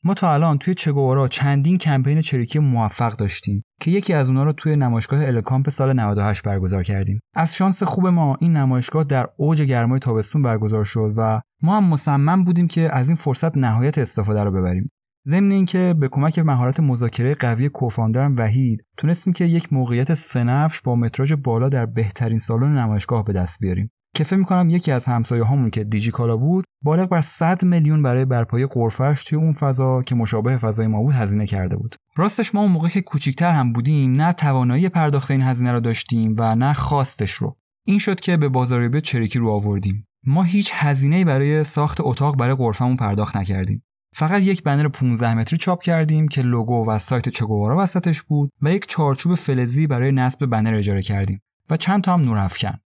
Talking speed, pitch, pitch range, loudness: 185 wpm, 135 Hz, 115-155 Hz, -19 LUFS